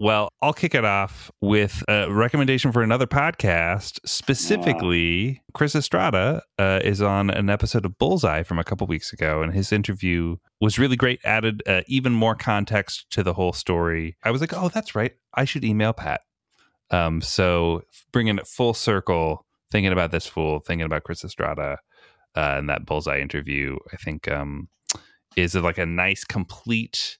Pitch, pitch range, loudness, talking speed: 100 Hz, 85-115 Hz, -23 LUFS, 170 wpm